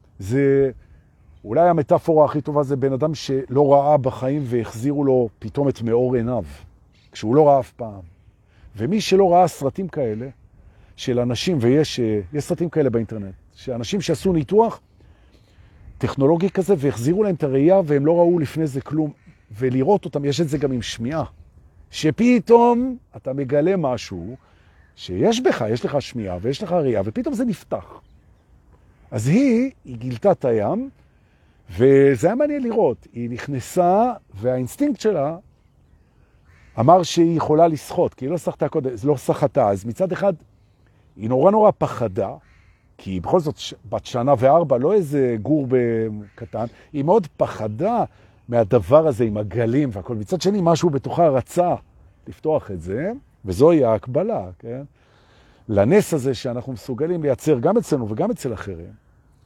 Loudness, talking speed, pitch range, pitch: -20 LUFS, 145 wpm, 110-165 Hz, 135 Hz